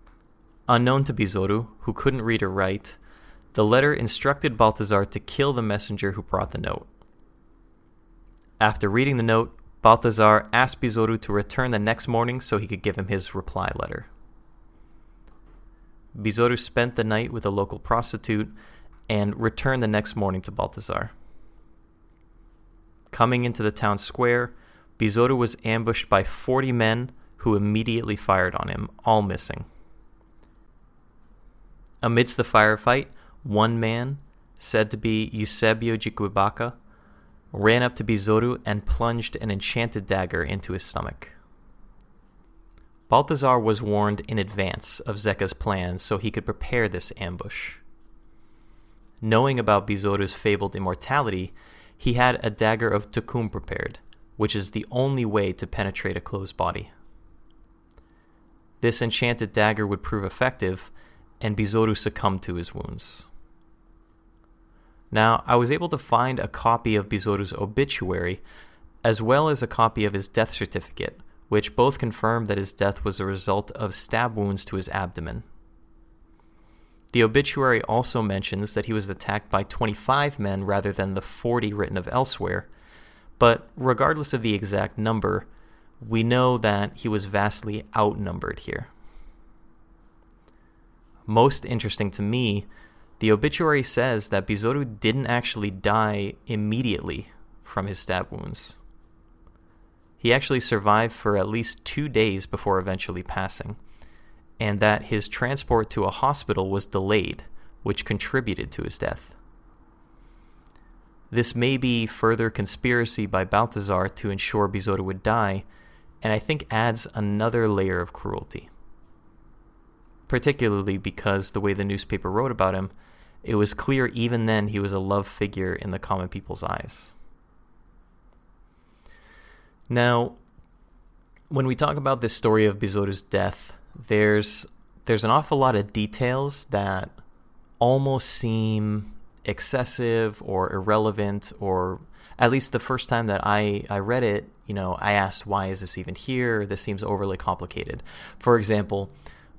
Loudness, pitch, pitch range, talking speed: -24 LUFS, 105 Hz, 95-115 Hz, 140 wpm